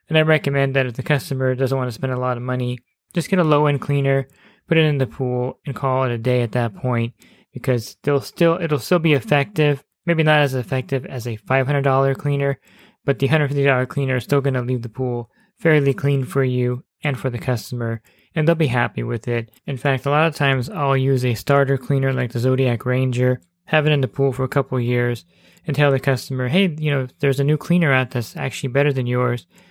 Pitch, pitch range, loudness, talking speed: 135 Hz, 125-145 Hz, -20 LUFS, 230 wpm